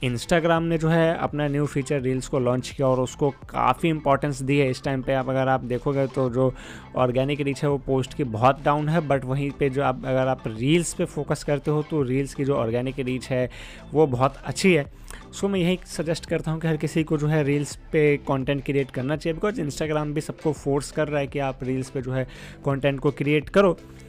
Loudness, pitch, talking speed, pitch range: -24 LUFS, 140 Hz, 235 wpm, 130-155 Hz